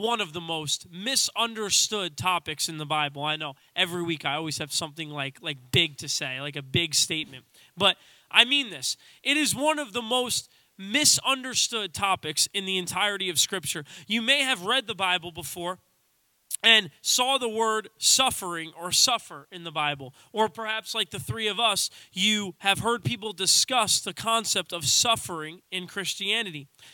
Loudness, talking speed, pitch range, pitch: -25 LUFS, 175 wpm, 155-225 Hz, 185 Hz